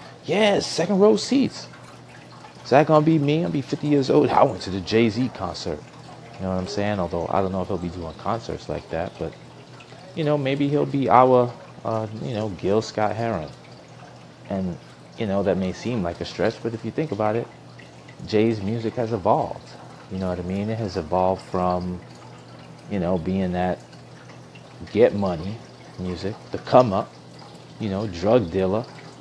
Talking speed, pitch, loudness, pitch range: 185 wpm, 105 Hz, -23 LUFS, 90-125 Hz